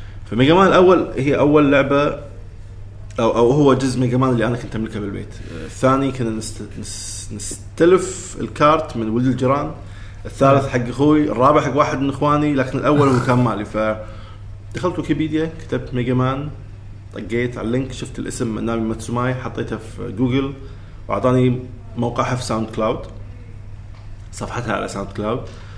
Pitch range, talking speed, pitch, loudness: 105-135 Hz, 140 wpm, 120 Hz, -18 LUFS